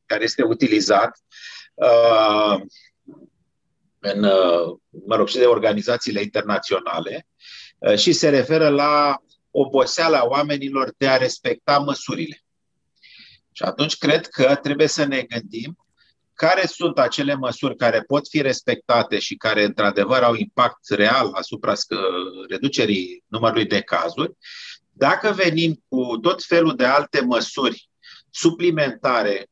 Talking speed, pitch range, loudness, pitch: 120 wpm, 120-165 Hz, -19 LUFS, 145 Hz